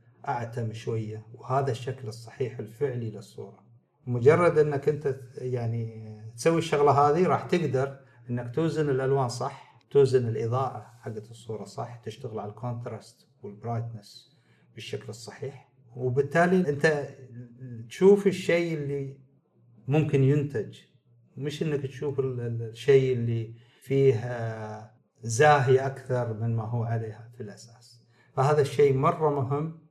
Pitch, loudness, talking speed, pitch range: 130 Hz, -26 LUFS, 110 wpm, 115-140 Hz